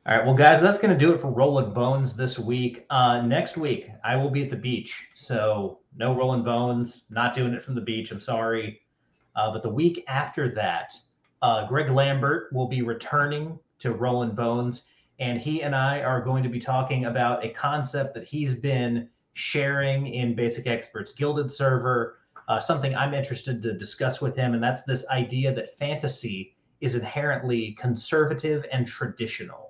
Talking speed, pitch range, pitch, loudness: 180 wpm, 120-140 Hz, 130 Hz, -25 LUFS